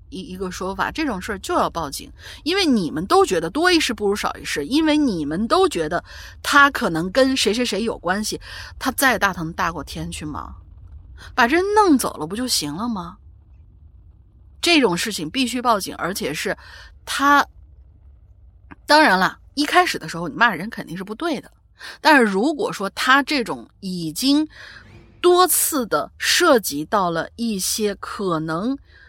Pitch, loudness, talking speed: 215 Hz, -19 LUFS, 240 characters per minute